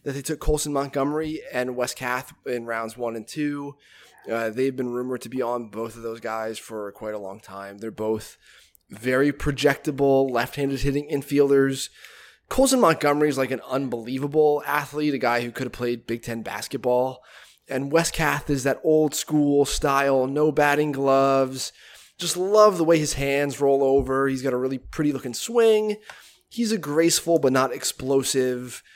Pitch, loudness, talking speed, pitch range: 135 Hz, -23 LUFS, 175 wpm, 125-150 Hz